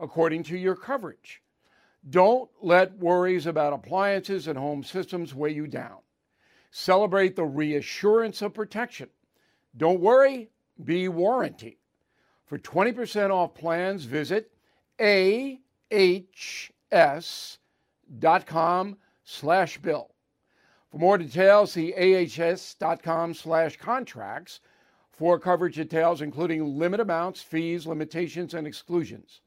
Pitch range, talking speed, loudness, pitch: 165-195 Hz, 100 wpm, -25 LUFS, 175 Hz